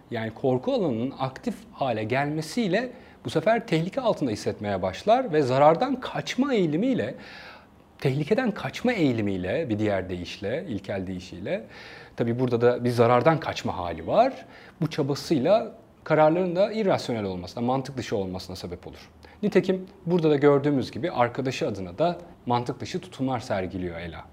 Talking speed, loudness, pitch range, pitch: 140 wpm, -26 LUFS, 110-180 Hz, 135 Hz